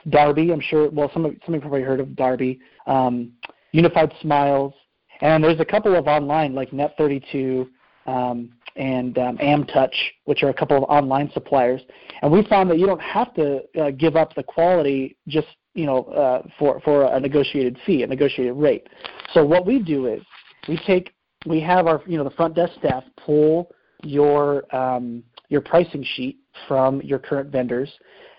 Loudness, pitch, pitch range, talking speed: -20 LUFS, 145 Hz, 135-160 Hz, 180 wpm